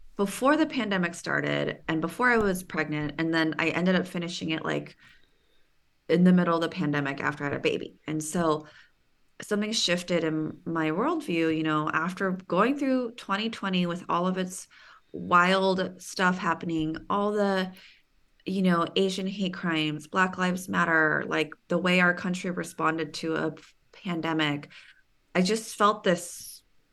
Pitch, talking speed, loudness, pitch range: 175 Hz, 160 wpm, -27 LUFS, 160-190 Hz